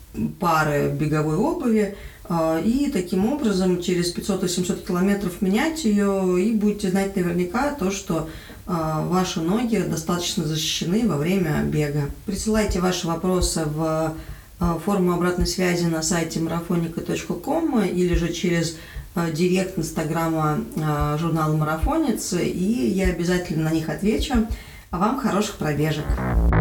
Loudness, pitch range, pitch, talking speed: -23 LUFS, 160-200 Hz, 180 Hz, 115 wpm